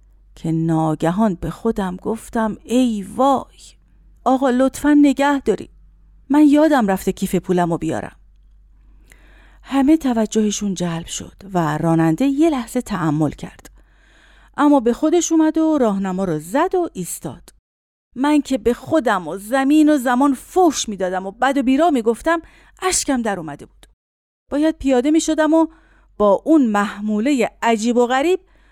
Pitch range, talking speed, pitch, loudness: 190-290 Hz, 145 wpm, 245 Hz, -18 LUFS